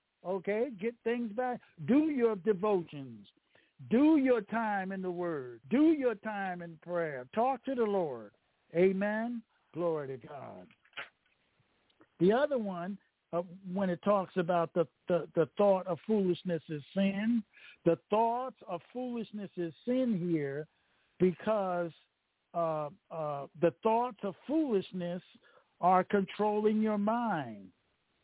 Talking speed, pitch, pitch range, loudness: 125 wpm, 195 Hz, 170-225 Hz, -32 LUFS